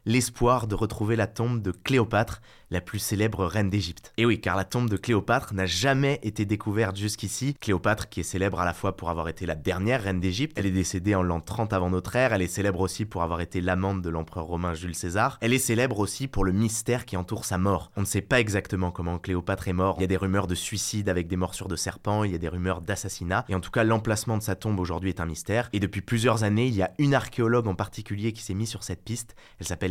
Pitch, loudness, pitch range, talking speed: 100 Hz, -27 LUFS, 95-115 Hz, 260 wpm